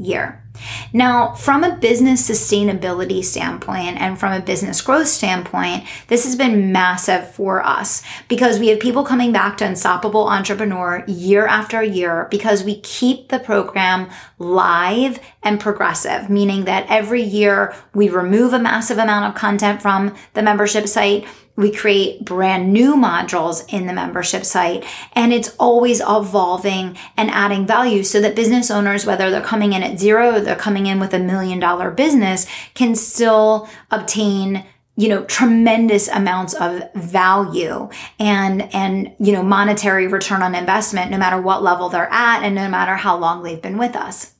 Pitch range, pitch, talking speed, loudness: 190-225 Hz, 205 Hz, 165 wpm, -16 LUFS